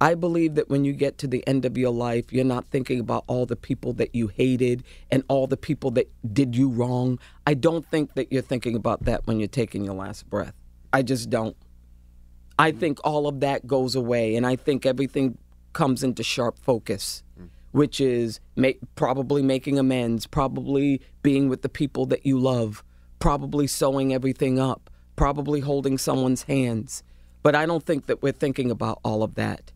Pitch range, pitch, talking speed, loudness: 115-140 Hz, 130 Hz, 190 wpm, -24 LUFS